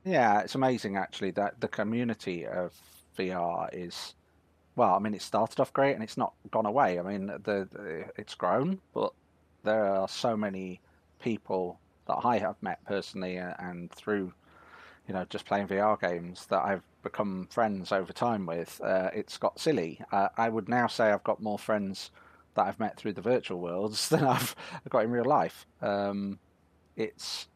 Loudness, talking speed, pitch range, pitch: -31 LUFS, 180 wpm, 90-110 Hz, 100 Hz